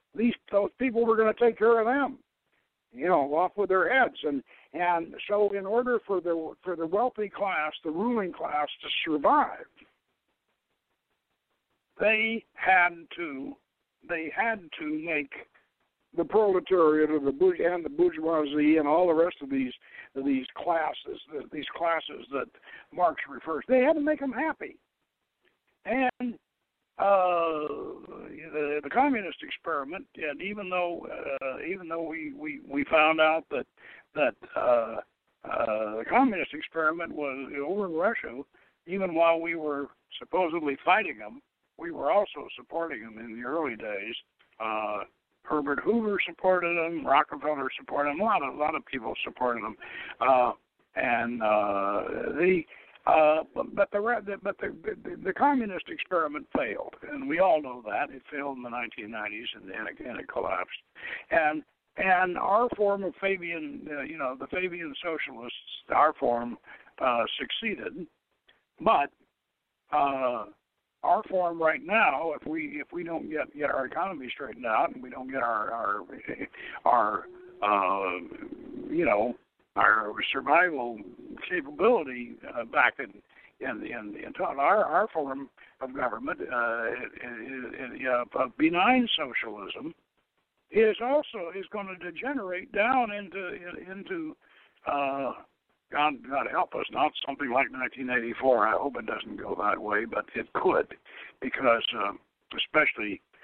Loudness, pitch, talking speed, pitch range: -28 LUFS, 180 Hz, 145 wpm, 150-235 Hz